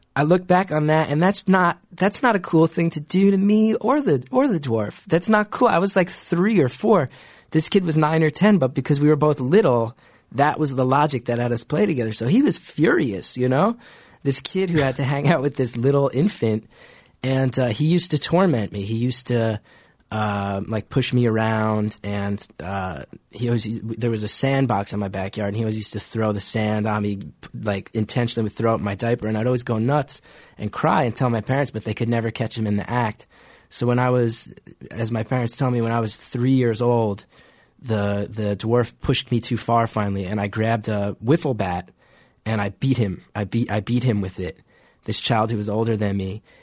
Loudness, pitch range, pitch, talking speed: -21 LUFS, 110-150 Hz, 120 Hz, 230 wpm